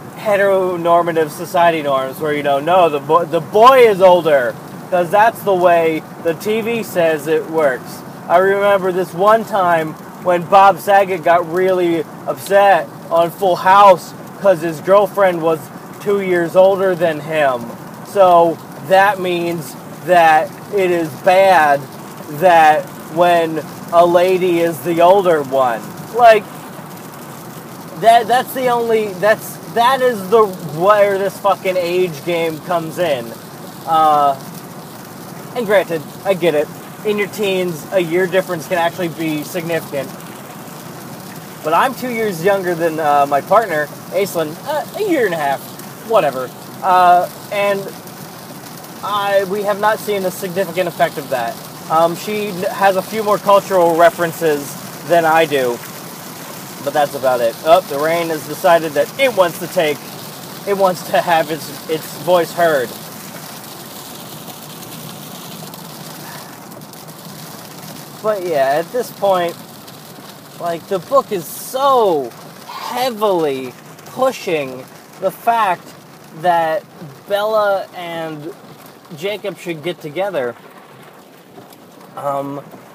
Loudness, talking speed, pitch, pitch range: -15 LUFS, 130 wpm, 180 Hz, 165-195 Hz